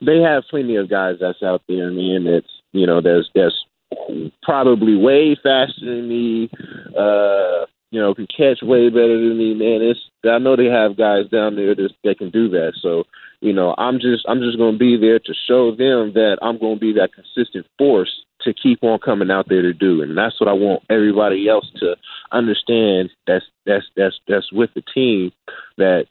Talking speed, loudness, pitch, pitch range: 200 wpm, -17 LUFS, 115 Hz, 100-120 Hz